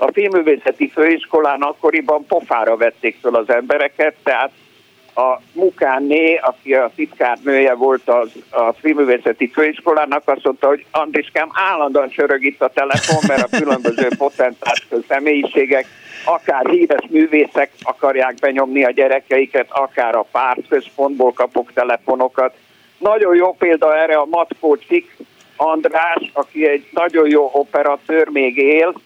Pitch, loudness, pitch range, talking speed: 145 Hz, -15 LUFS, 135-160 Hz, 125 wpm